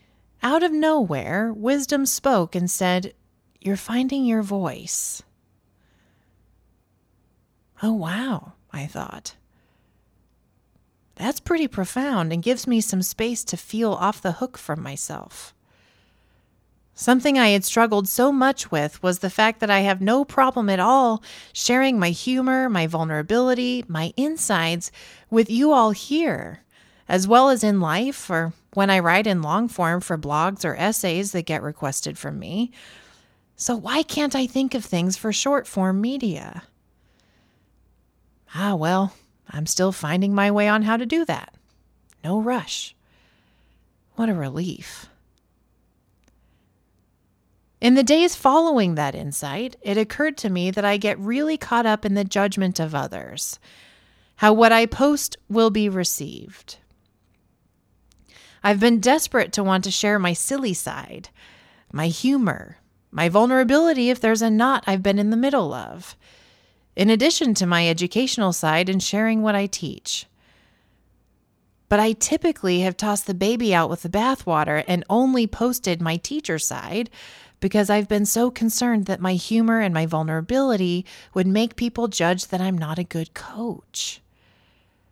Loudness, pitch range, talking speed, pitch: -21 LUFS, 160-235 Hz, 145 wpm, 200 Hz